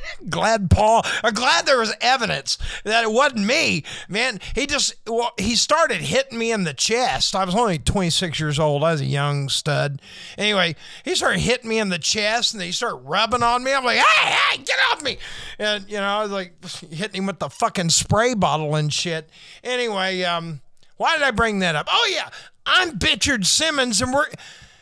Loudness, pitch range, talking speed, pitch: -20 LUFS, 175-240 Hz, 205 wpm, 210 Hz